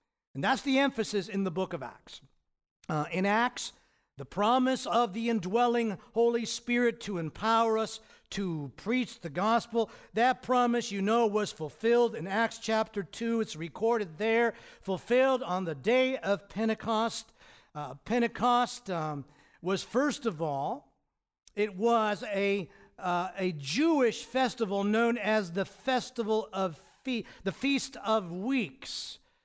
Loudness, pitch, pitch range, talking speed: -30 LUFS, 220 Hz, 190-235 Hz, 140 wpm